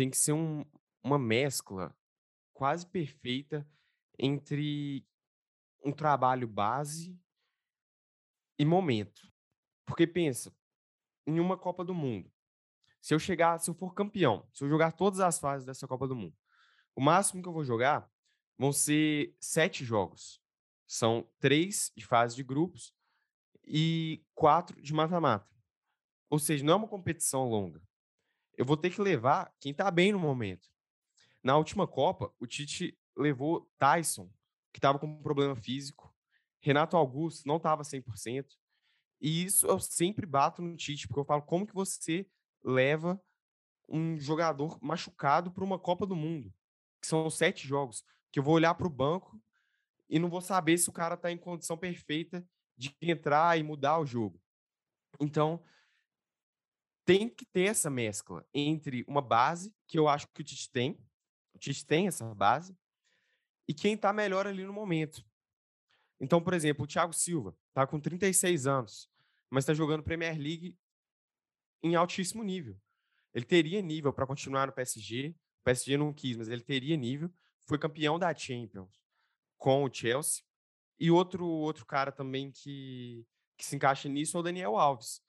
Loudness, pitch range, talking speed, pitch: -31 LUFS, 135-170 Hz, 160 wpm, 150 Hz